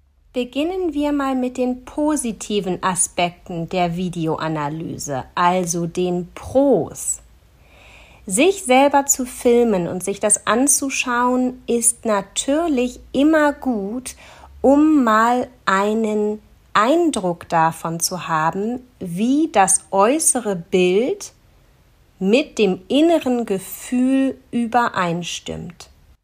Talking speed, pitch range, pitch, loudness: 90 wpm, 175-260 Hz, 215 Hz, -19 LUFS